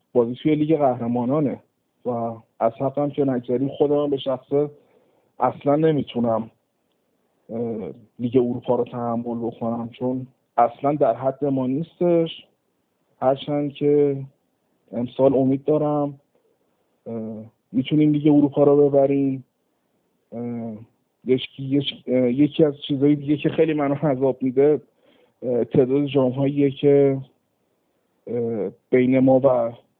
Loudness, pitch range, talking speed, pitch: -21 LUFS, 120-145 Hz, 100 wpm, 135 Hz